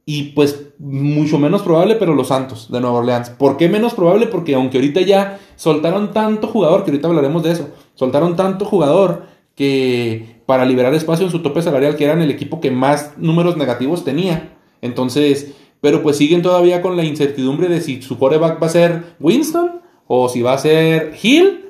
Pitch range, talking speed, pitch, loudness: 140-180 Hz, 190 wpm, 155 Hz, -15 LUFS